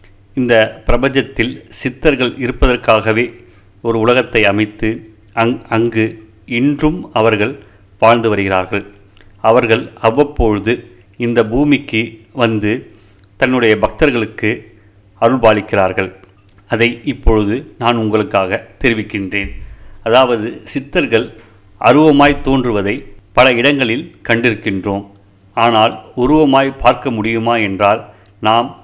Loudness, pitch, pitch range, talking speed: -14 LUFS, 110 Hz, 100-125 Hz, 80 wpm